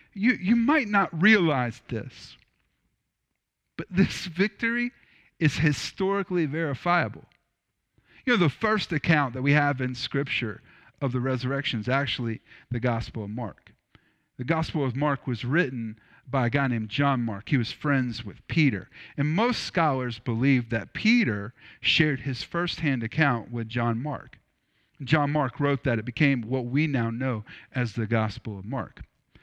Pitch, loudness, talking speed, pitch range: 135 Hz, -26 LUFS, 155 wpm, 120-160 Hz